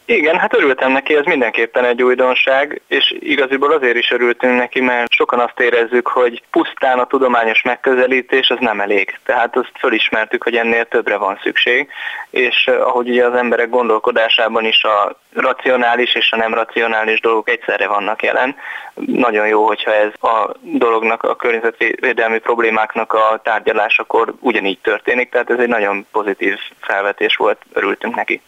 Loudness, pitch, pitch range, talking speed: -14 LUFS, 125 Hz, 115-140 Hz, 155 wpm